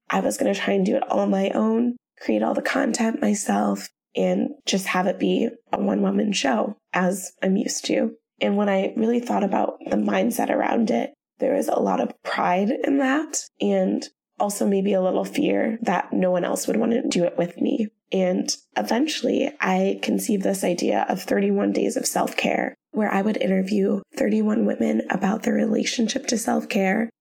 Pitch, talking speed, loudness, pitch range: 220 Hz, 195 wpm, -23 LUFS, 195-245 Hz